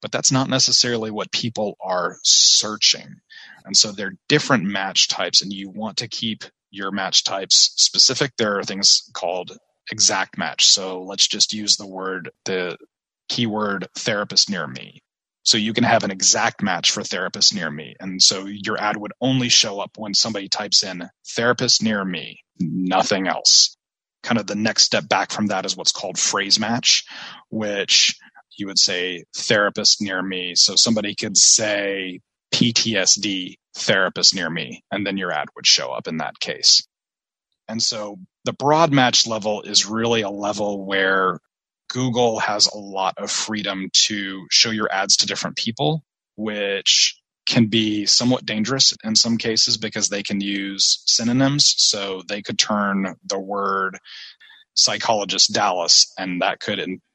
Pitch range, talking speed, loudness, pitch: 95-115 Hz, 165 wpm, -18 LUFS, 105 Hz